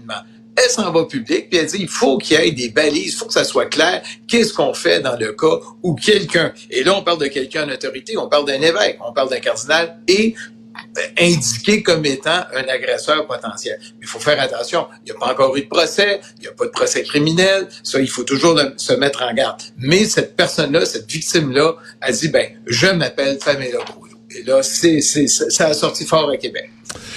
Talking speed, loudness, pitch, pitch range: 230 wpm, -16 LUFS, 160 Hz, 135-215 Hz